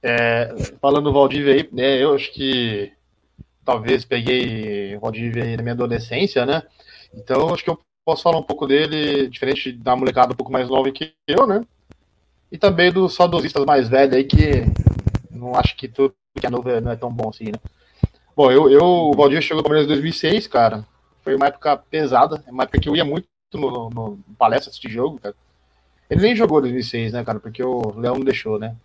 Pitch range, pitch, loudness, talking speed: 115-145 Hz, 130 Hz, -18 LUFS, 200 wpm